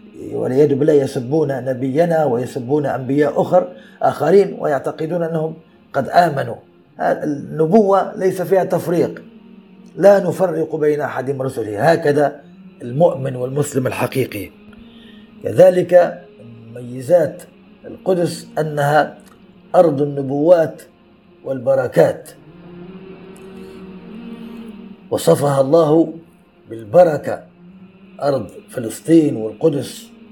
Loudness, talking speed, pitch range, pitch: -17 LUFS, 75 wpm, 145-190 Hz, 165 Hz